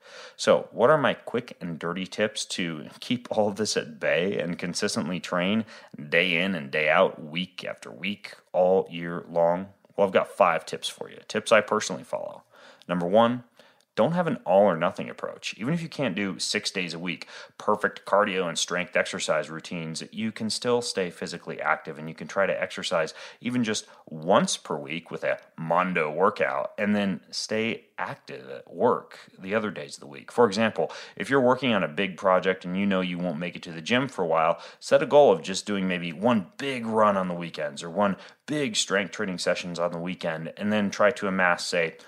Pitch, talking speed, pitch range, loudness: 95 Hz, 210 wpm, 85-120 Hz, -26 LUFS